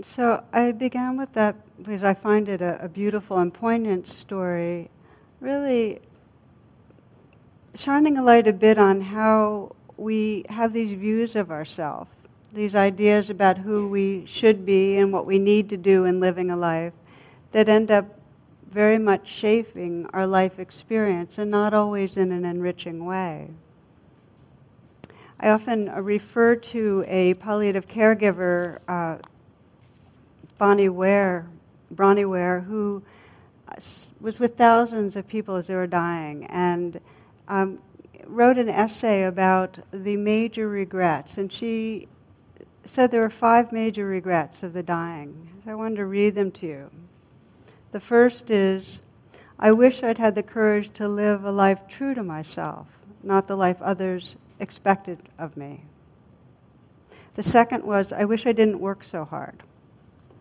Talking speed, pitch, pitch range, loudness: 145 wpm, 200 Hz, 180-215 Hz, -22 LUFS